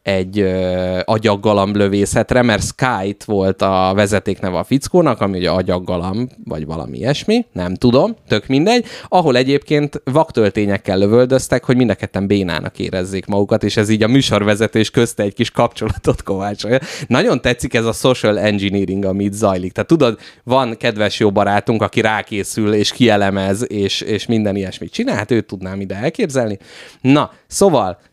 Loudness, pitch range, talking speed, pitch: -16 LUFS, 100-125 Hz, 145 wpm, 105 Hz